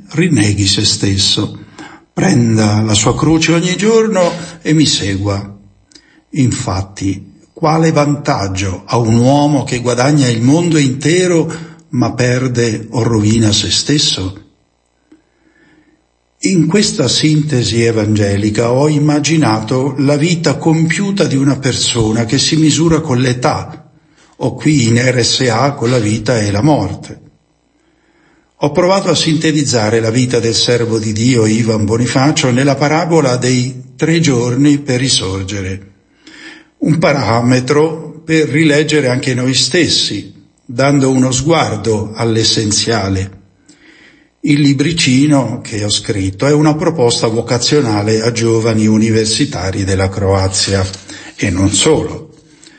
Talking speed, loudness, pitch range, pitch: 115 wpm, -12 LUFS, 110-150 Hz, 125 Hz